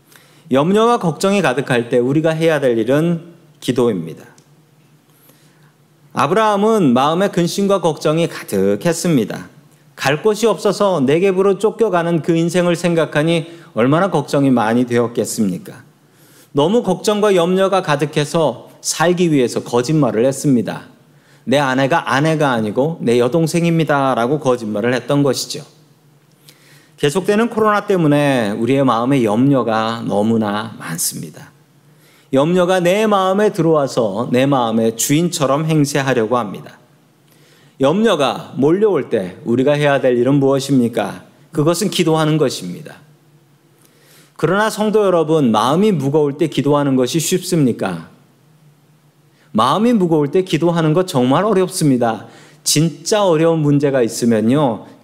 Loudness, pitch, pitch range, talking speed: -15 LUFS, 155 Hz, 135-170 Hz, 295 characters per minute